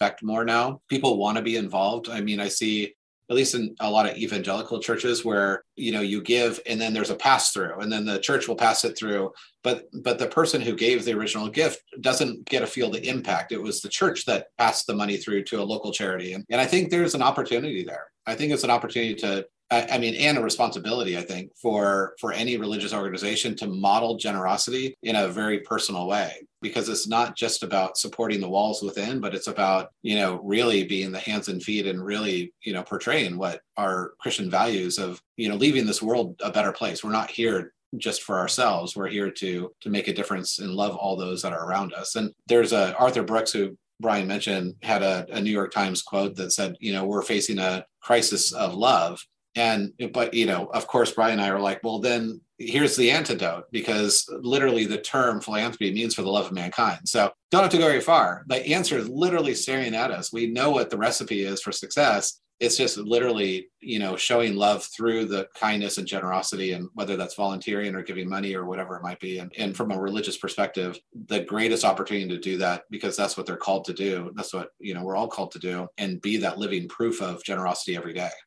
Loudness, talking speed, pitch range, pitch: -25 LUFS, 225 wpm, 95-115 Hz, 105 Hz